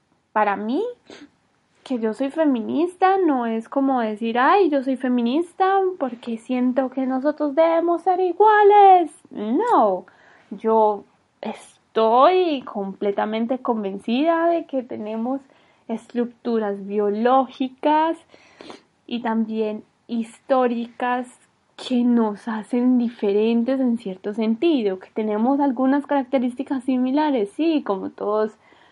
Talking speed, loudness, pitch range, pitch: 100 wpm, -21 LUFS, 225-295 Hz, 255 Hz